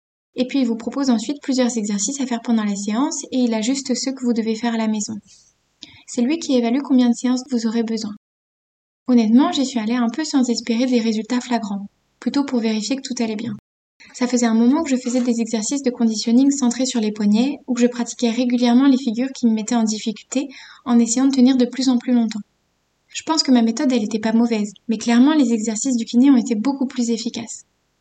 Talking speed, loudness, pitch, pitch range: 230 wpm, -19 LUFS, 240 Hz, 230-260 Hz